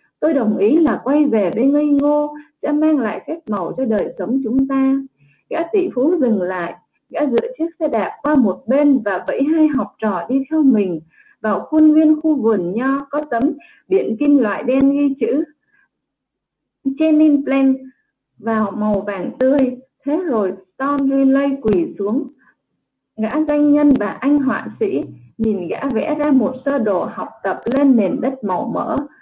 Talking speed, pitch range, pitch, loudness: 180 wpm, 225-295 Hz, 270 Hz, -17 LUFS